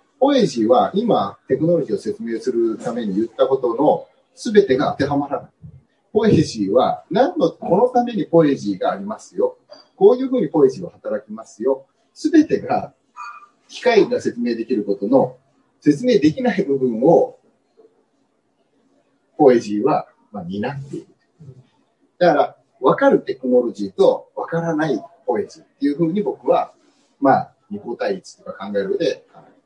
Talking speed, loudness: 310 characters per minute, -19 LUFS